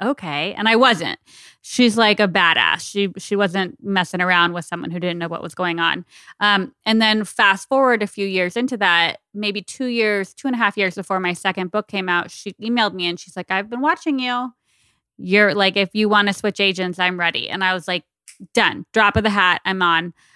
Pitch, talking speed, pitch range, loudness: 195 Hz, 225 wpm, 180-215 Hz, -18 LUFS